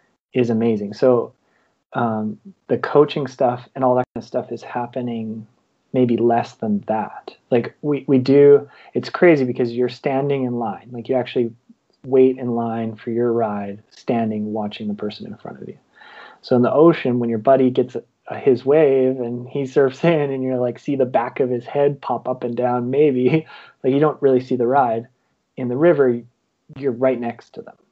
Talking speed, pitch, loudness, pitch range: 200 wpm, 125 Hz, -19 LUFS, 120-135 Hz